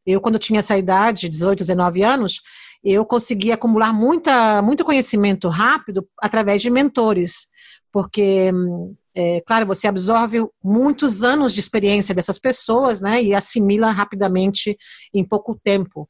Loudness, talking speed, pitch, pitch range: -18 LUFS, 135 wpm, 210 Hz, 195-230 Hz